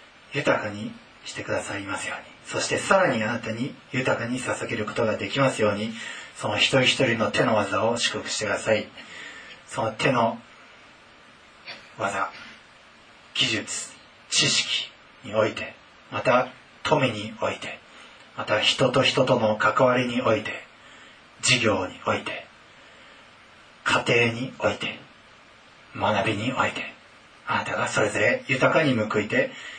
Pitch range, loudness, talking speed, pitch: 110-130 Hz, -24 LUFS, 255 characters per minute, 120 Hz